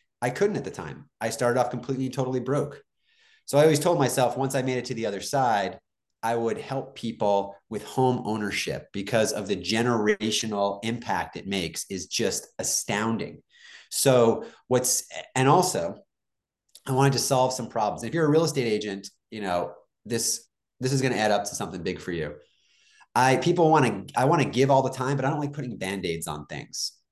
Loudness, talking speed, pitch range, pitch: -26 LUFS, 200 wpm, 105-135 Hz, 125 Hz